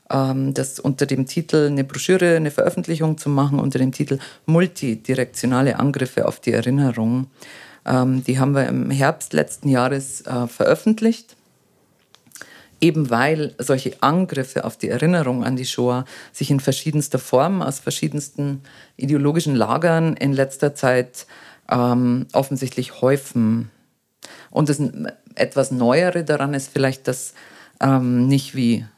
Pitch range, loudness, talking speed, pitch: 125-150 Hz, -20 LUFS, 130 wpm, 135 Hz